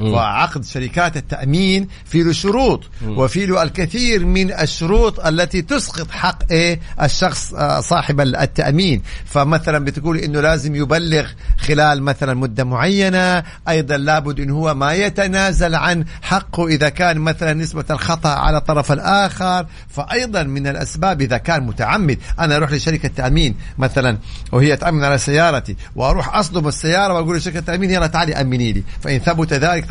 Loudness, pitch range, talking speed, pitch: -17 LUFS, 140-175 Hz, 135 wpm, 155 Hz